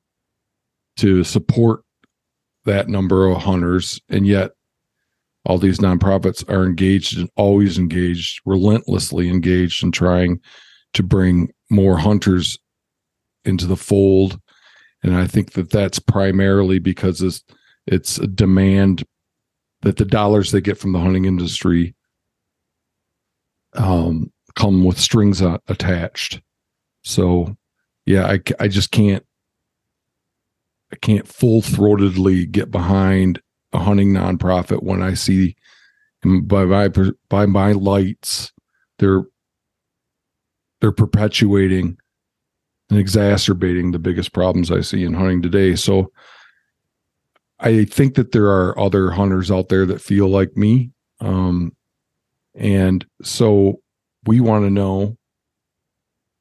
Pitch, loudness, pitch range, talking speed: 95 Hz, -17 LUFS, 90-100 Hz, 115 wpm